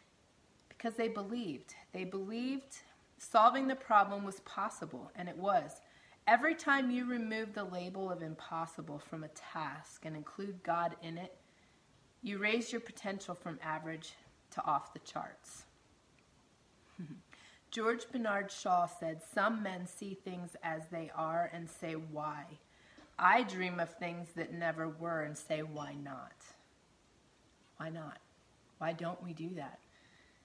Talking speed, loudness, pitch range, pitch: 140 wpm, -37 LUFS, 160-205 Hz, 175 Hz